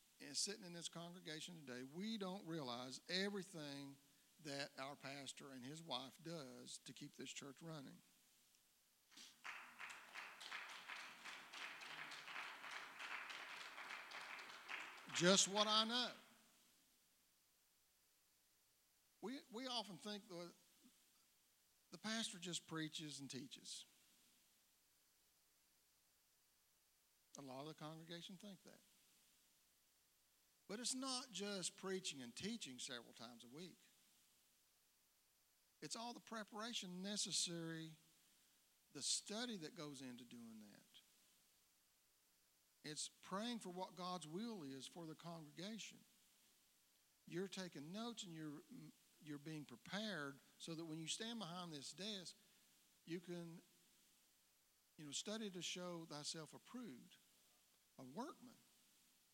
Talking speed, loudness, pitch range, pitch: 105 wpm, -49 LUFS, 135-200 Hz, 165 Hz